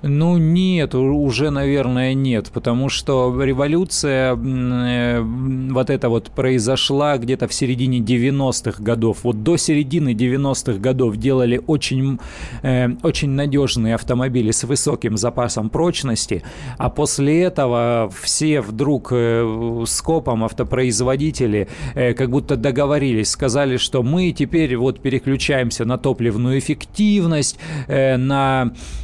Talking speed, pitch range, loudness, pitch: 120 wpm, 120-140 Hz, -18 LUFS, 130 Hz